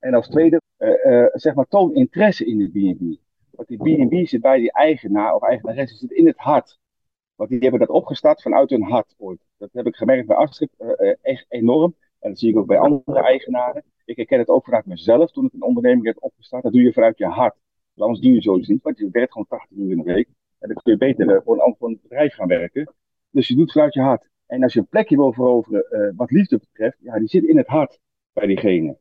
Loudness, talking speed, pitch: -18 LUFS, 255 wpm, 155 Hz